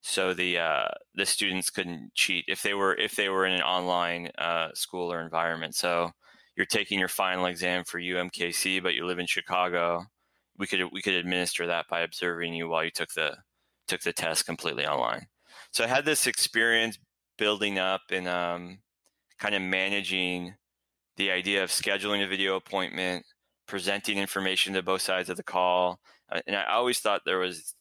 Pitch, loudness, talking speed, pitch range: 90 Hz, -28 LUFS, 180 wpm, 85-95 Hz